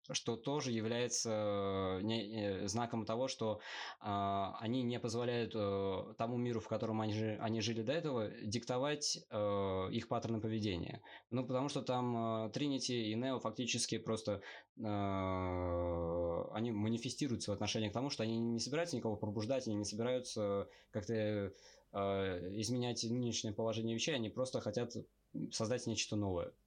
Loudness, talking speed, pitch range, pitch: -39 LUFS, 125 wpm, 105-120 Hz, 110 Hz